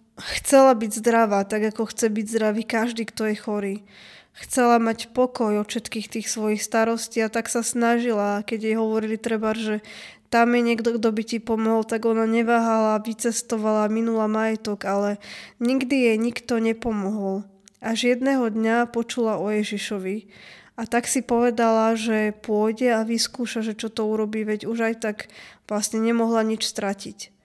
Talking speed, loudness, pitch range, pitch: 160 wpm, -23 LUFS, 215-230 Hz, 225 Hz